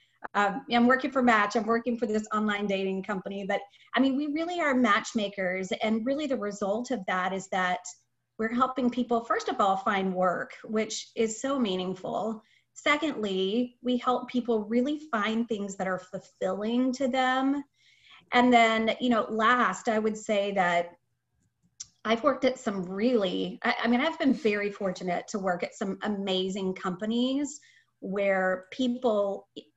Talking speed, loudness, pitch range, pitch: 160 wpm, -28 LUFS, 195-245 Hz, 220 Hz